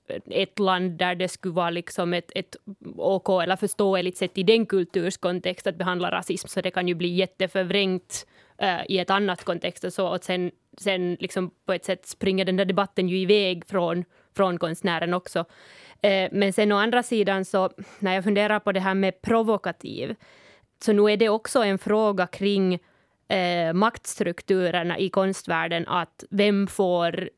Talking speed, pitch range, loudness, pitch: 175 wpm, 180-200 Hz, -24 LUFS, 190 Hz